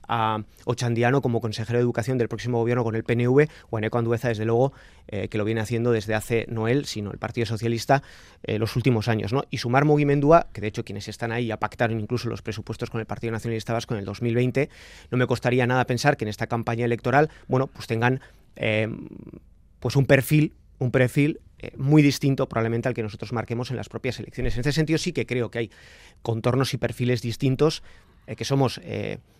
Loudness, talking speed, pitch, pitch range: -24 LUFS, 215 wpm, 120 Hz, 110-130 Hz